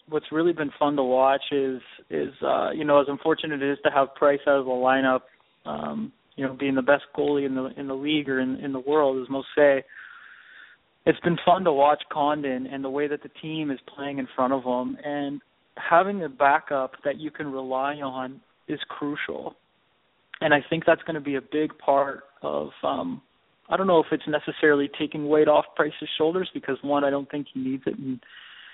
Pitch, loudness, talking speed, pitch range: 145 Hz, -25 LUFS, 215 wpm, 135-150 Hz